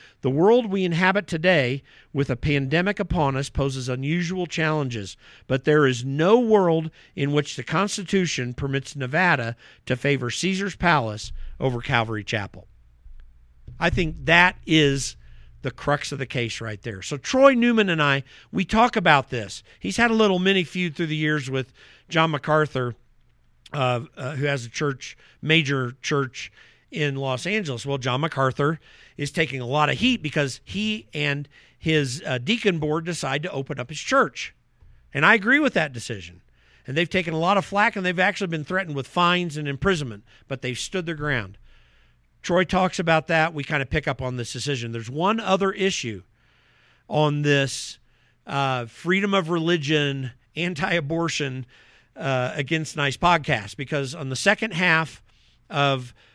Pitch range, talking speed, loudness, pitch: 130-175 Hz, 165 wpm, -23 LUFS, 145 Hz